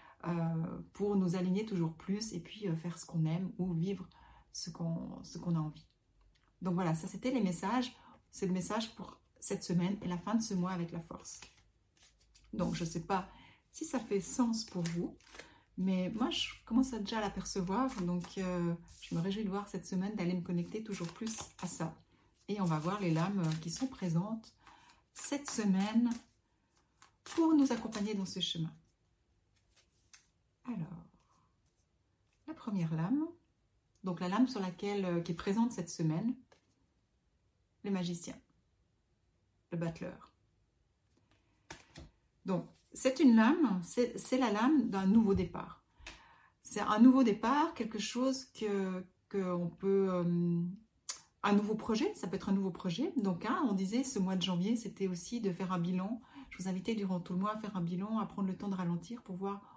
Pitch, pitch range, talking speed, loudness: 190 Hz, 175-220 Hz, 175 wpm, -35 LUFS